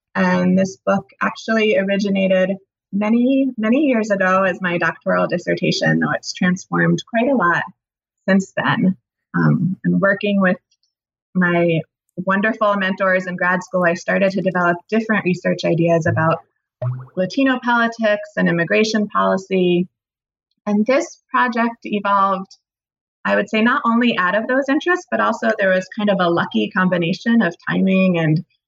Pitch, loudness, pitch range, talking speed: 190 Hz, -18 LUFS, 175-220 Hz, 145 wpm